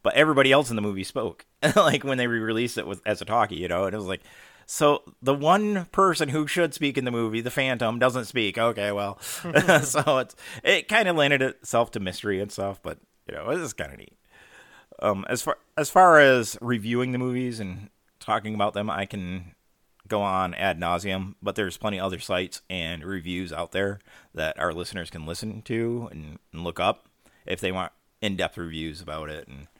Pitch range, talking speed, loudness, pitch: 95-125 Hz, 210 wpm, -25 LUFS, 110 Hz